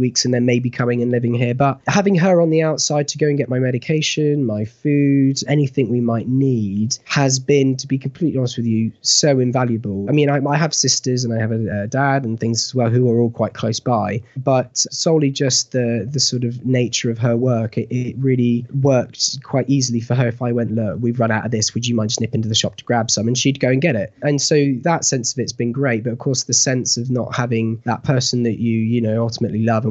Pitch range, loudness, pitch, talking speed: 115-135 Hz, -18 LUFS, 125 Hz, 255 wpm